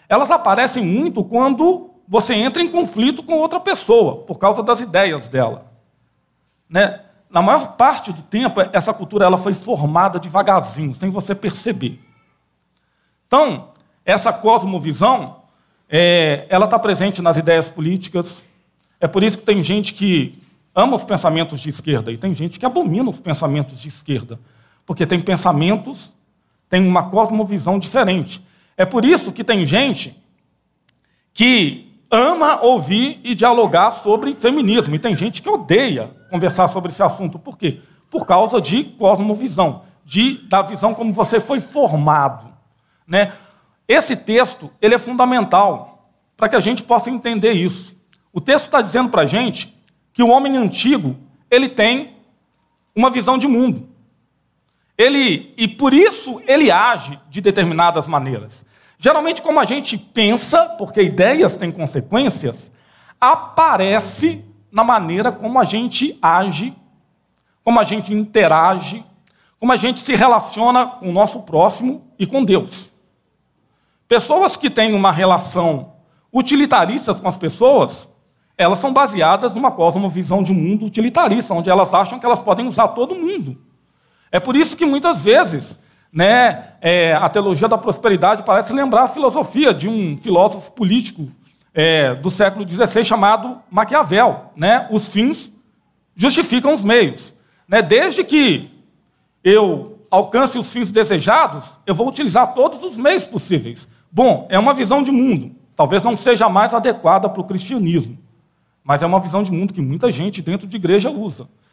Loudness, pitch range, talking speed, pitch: -15 LUFS, 180-245 Hz, 150 wpm, 210 Hz